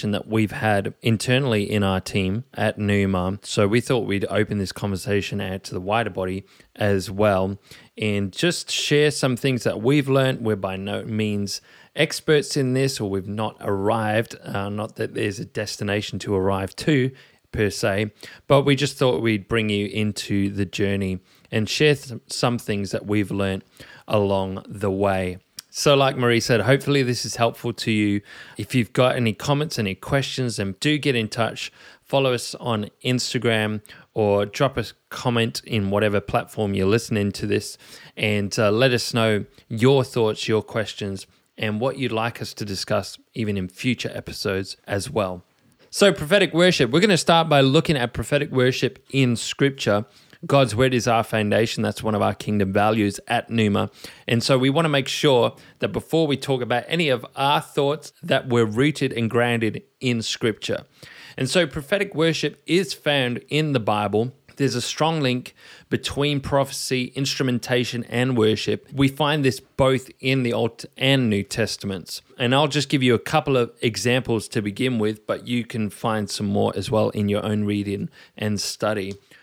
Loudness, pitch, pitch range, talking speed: -22 LUFS, 115 Hz, 105-135 Hz, 180 wpm